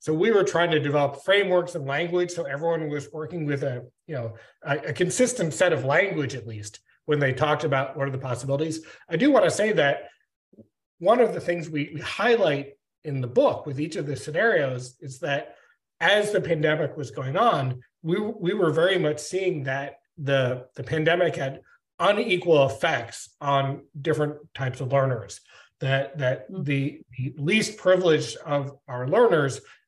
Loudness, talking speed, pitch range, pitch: -24 LUFS, 180 wpm, 135-170 Hz, 150 Hz